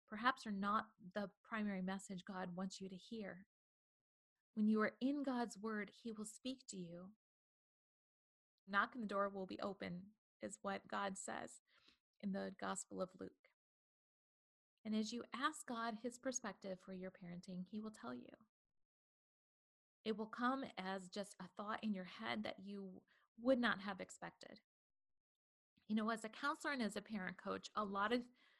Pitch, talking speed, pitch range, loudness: 210 Hz, 170 wpm, 195-235 Hz, -45 LUFS